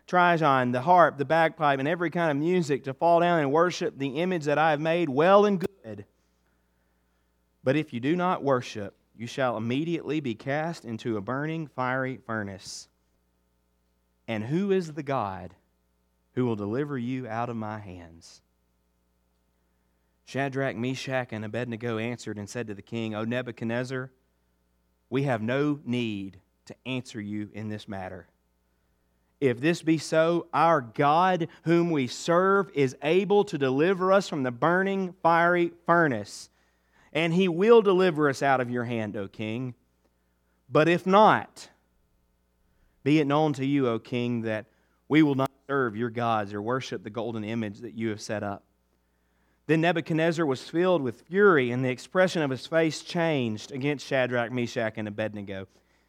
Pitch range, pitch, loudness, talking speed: 100-155 Hz, 125 Hz, -26 LUFS, 160 wpm